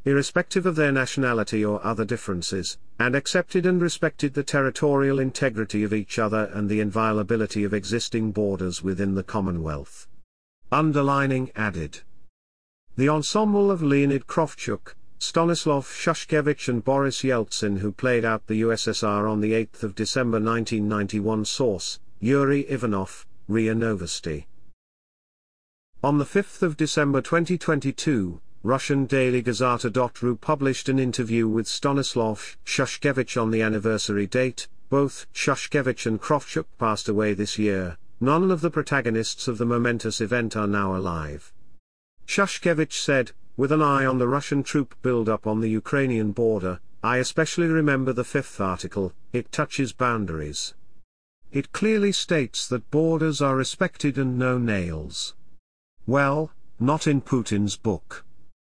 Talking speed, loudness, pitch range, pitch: 135 wpm, -24 LUFS, 105-140 Hz, 120 Hz